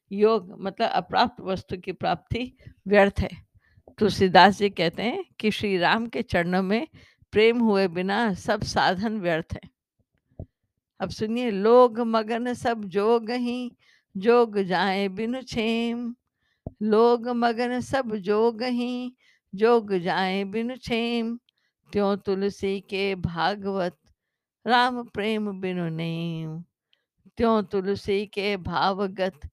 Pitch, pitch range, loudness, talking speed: 210 Hz, 195-235 Hz, -24 LUFS, 110 wpm